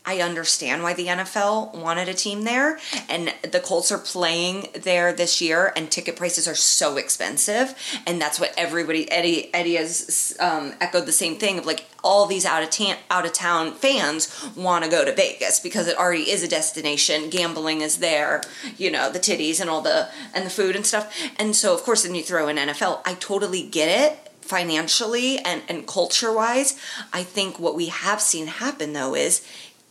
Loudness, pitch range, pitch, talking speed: -21 LUFS, 165-210 Hz, 180 Hz, 200 wpm